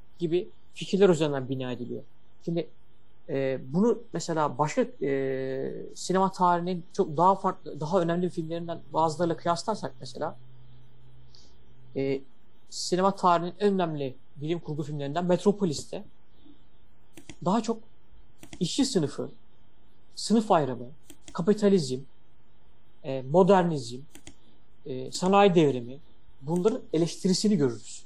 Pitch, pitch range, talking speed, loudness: 165 Hz, 130-185 Hz, 100 wpm, -27 LUFS